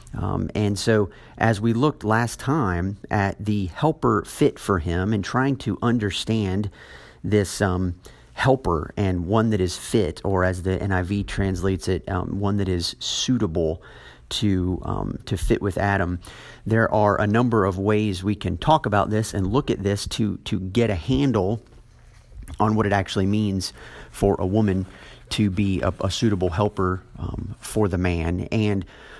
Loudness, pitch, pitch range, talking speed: -23 LUFS, 100 Hz, 95-110 Hz, 170 wpm